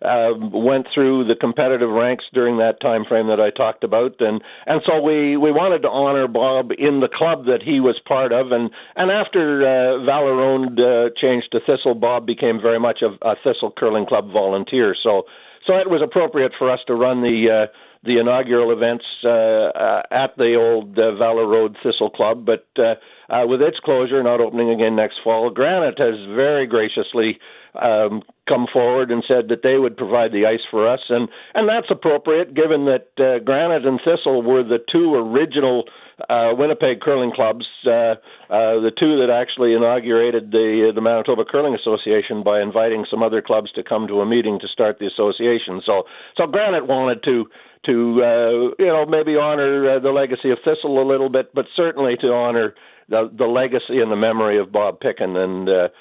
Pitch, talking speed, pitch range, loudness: 120 Hz, 190 wpm, 115-135 Hz, -18 LUFS